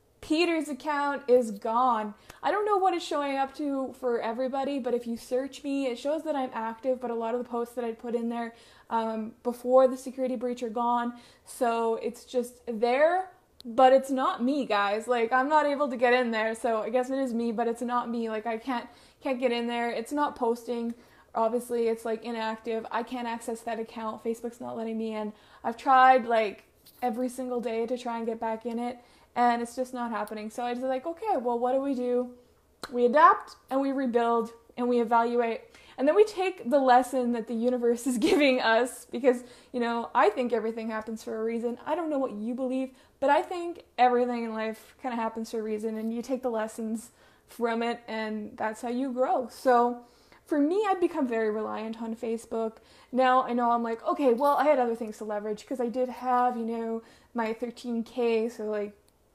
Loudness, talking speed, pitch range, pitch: -28 LUFS, 215 wpm, 230-260 Hz, 240 Hz